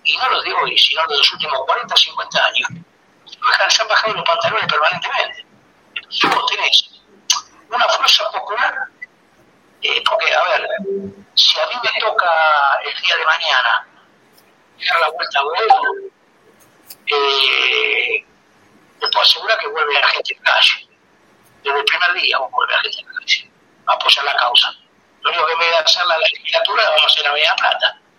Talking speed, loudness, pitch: 170 wpm, -15 LUFS, 340 Hz